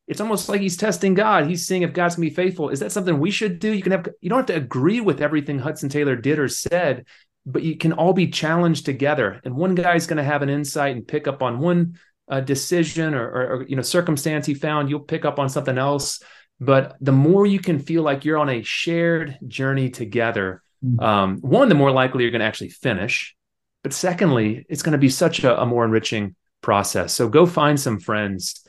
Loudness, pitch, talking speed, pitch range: -20 LUFS, 150 Hz, 230 wpm, 130-170 Hz